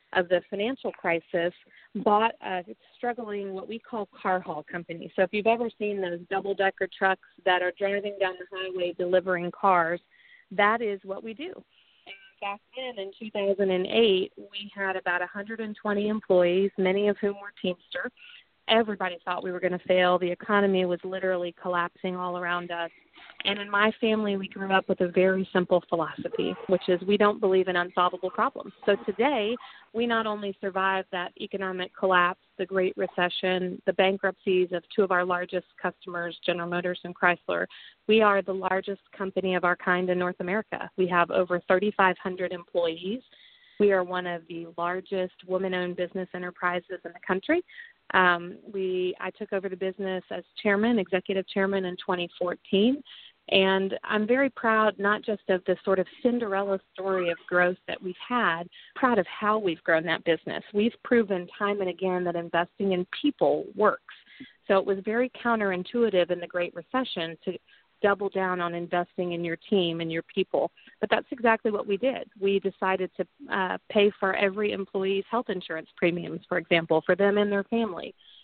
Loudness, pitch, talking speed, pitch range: -27 LUFS, 190 Hz, 175 wpm, 180-205 Hz